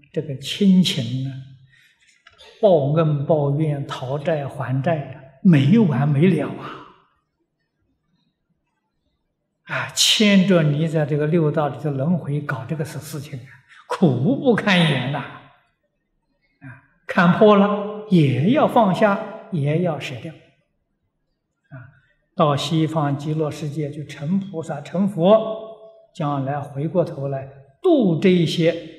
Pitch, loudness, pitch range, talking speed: 155 Hz, -19 LUFS, 145-180 Hz, 165 characters per minute